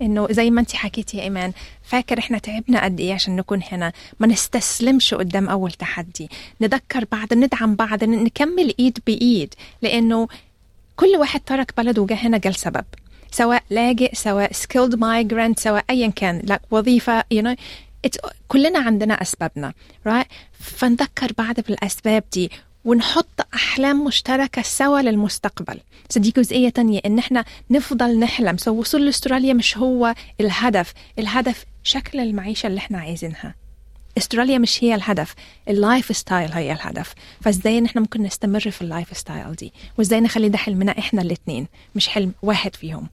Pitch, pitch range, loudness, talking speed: 225 Hz, 200-245 Hz, -19 LUFS, 150 wpm